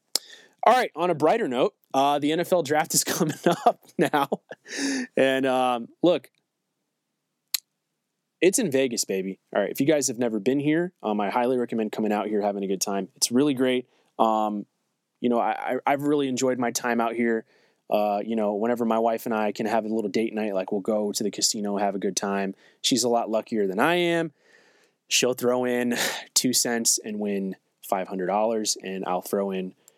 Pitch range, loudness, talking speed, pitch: 105-135 Hz, -25 LUFS, 200 wpm, 120 Hz